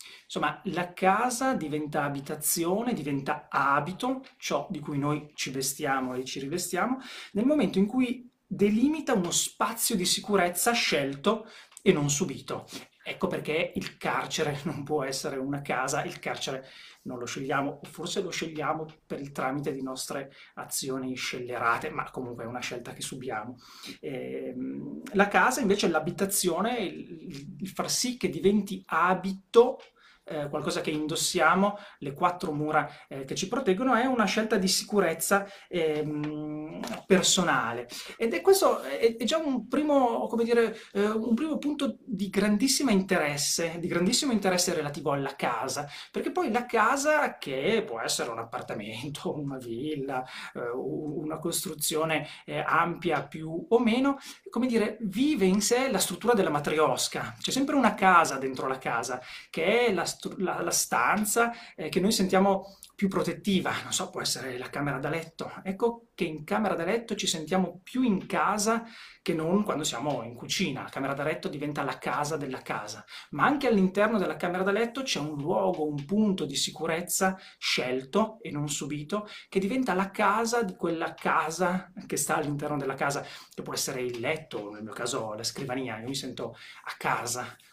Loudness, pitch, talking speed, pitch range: -28 LUFS, 180 Hz, 165 wpm, 150-210 Hz